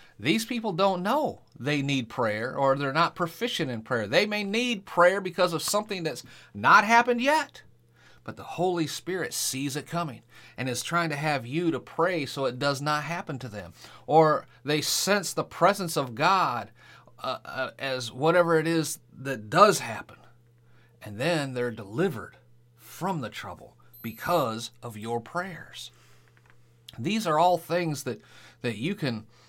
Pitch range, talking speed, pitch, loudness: 120-175 Hz, 165 wpm, 150 Hz, -26 LUFS